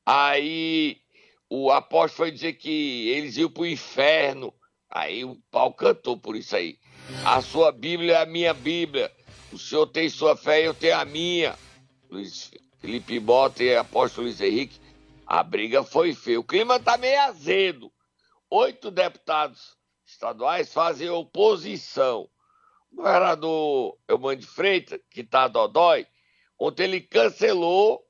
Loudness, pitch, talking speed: -23 LUFS, 325 Hz, 155 wpm